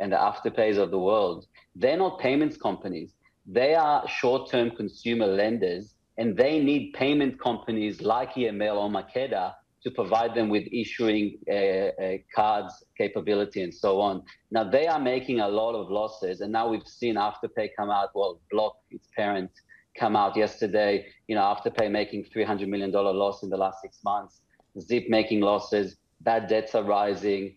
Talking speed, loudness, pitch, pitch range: 165 wpm, -27 LUFS, 110 Hz, 100-120 Hz